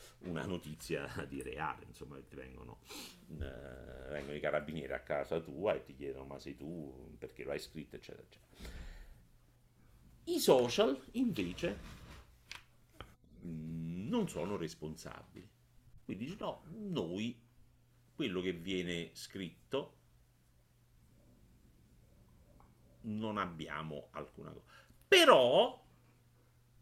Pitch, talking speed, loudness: 85 Hz, 100 wpm, -36 LUFS